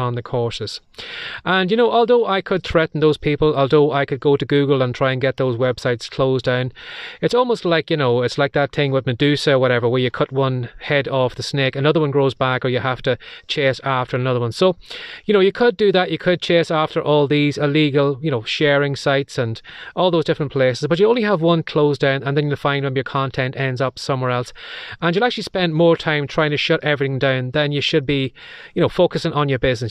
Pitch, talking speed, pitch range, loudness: 145 Hz, 245 wpm, 130-165 Hz, -18 LUFS